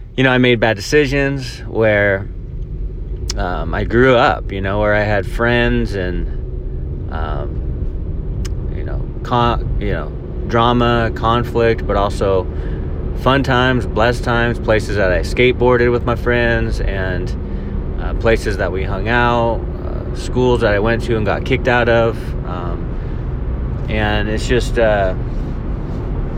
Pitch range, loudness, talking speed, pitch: 95-120 Hz, -17 LUFS, 140 wpm, 110 Hz